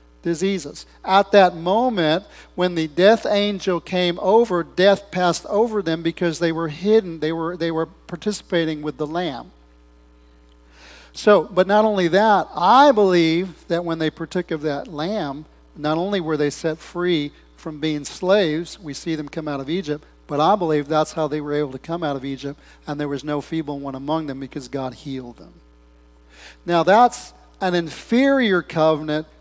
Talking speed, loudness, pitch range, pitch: 175 wpm, -20 LUFS, 145-180 Hz, 160 Hz